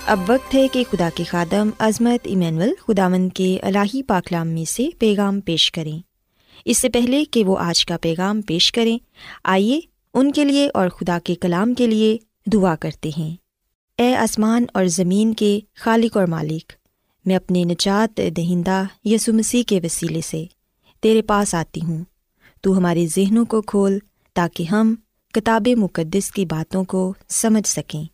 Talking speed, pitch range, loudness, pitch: 160 wpm, 175-225 Hz, -19 LUFS, 195 Hz